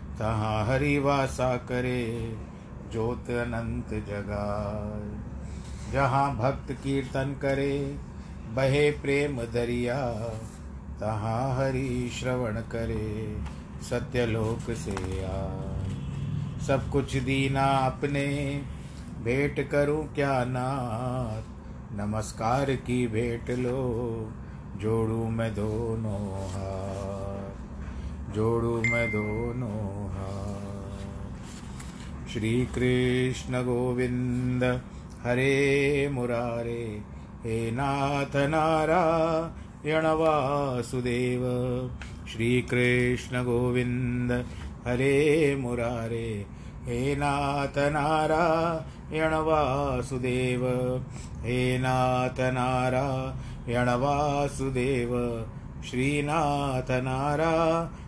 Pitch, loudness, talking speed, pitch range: 125 Hz, -28 LUFS, 65 wpm, 110-135 Hz